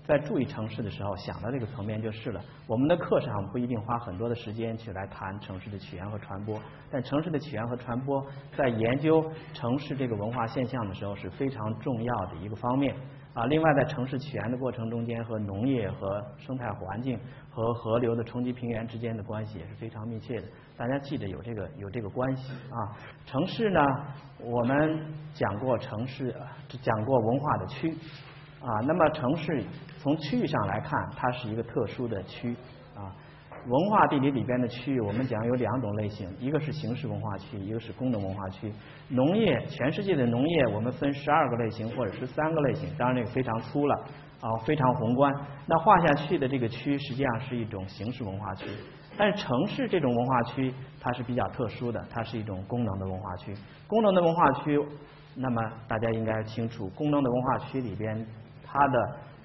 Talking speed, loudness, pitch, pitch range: 305 characters per minute, -30 LUFS, 125 Hz, 110-140 Hz